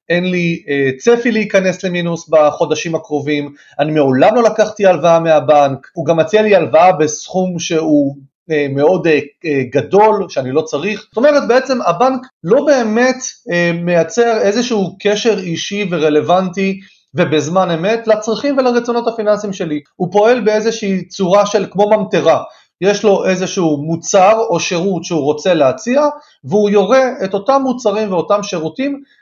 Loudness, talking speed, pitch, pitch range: -13 LUFS, 135 wpm, 190 Hz, 160-215 Hz